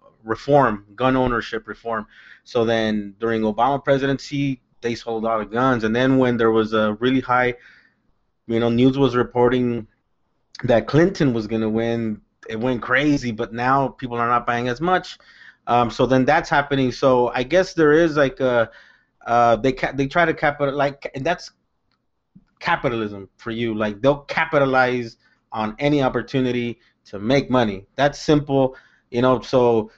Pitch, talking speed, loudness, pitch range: 125 Hz, 165 wpm, -20 LUFS, 115-140 Hz